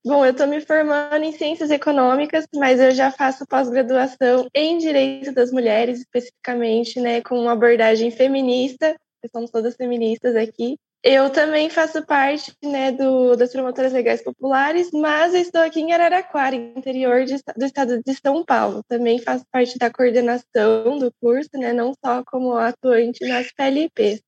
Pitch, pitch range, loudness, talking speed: 260 Hz, 245-285 Hz, -19 LUFS, 160 wpm